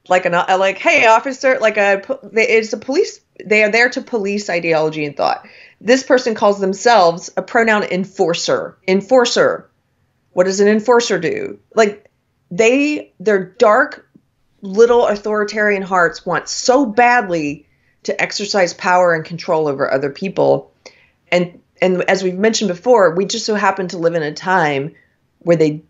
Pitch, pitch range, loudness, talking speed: 195 Hz, 175-230 Hz, -15 LUFS, 155 wpm